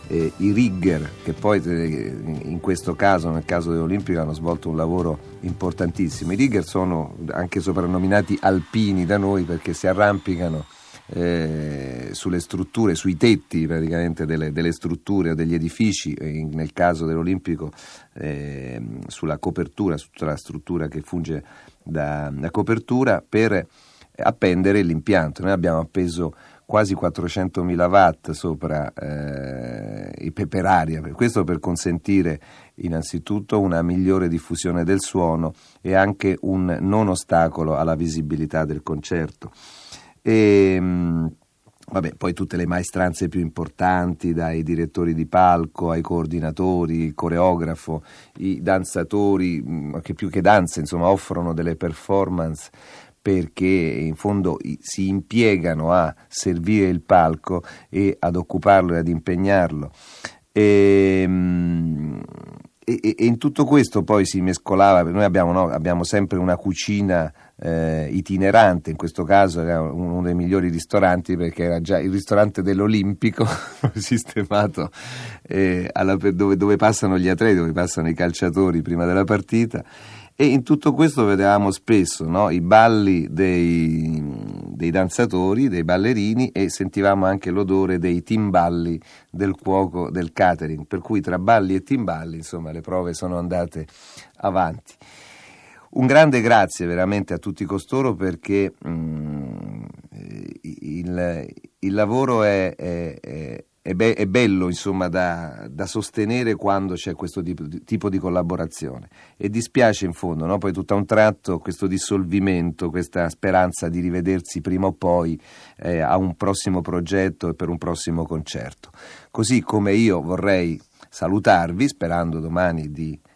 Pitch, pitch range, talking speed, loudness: 90 Hz, 85-100 Hz, 135 wpm, -21 LUFS